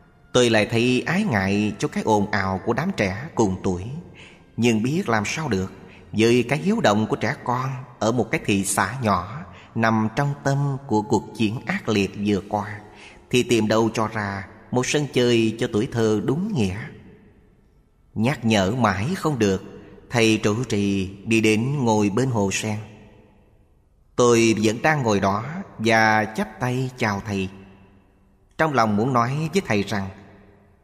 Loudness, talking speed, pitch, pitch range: -22 LUFS, 165 wpm, 110 Hz, 100-125 Hz